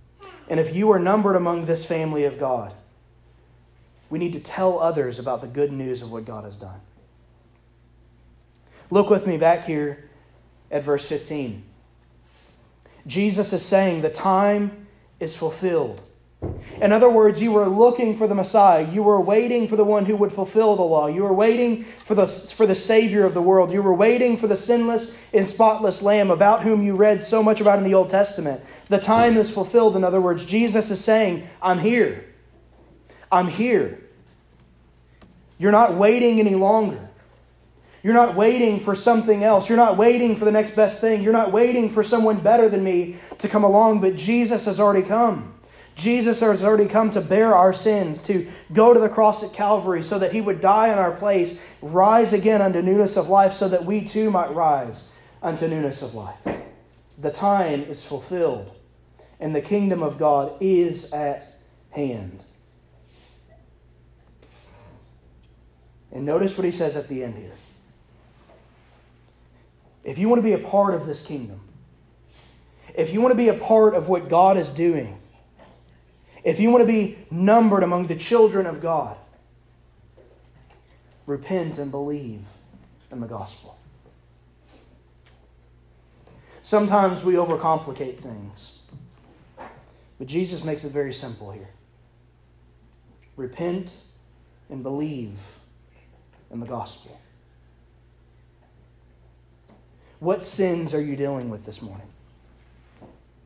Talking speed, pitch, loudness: 155 wpm, 170 Hz, -19 LUFS